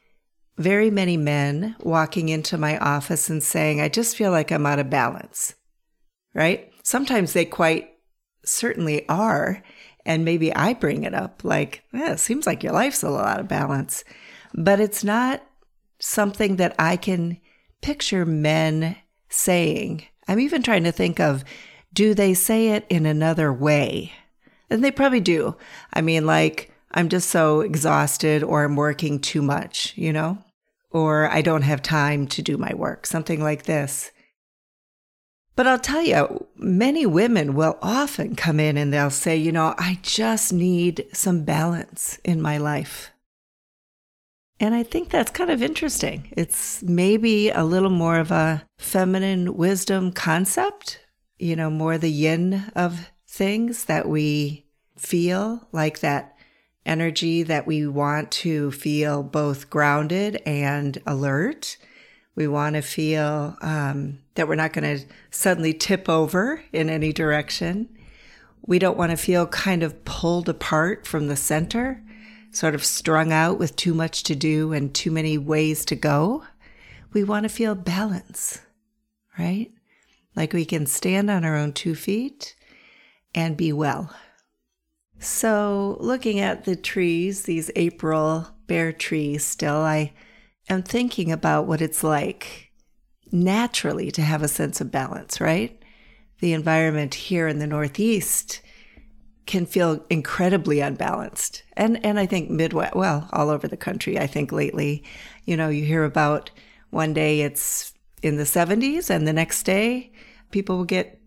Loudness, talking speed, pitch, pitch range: -22 LUFS, 155 wpm, 165 Hz, 155-200 Hz